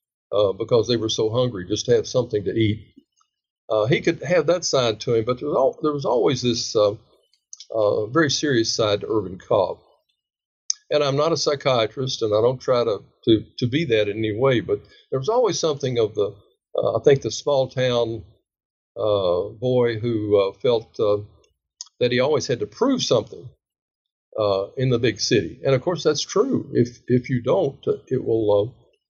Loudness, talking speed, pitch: -22 LUFS, 200 wpm, 125 Hz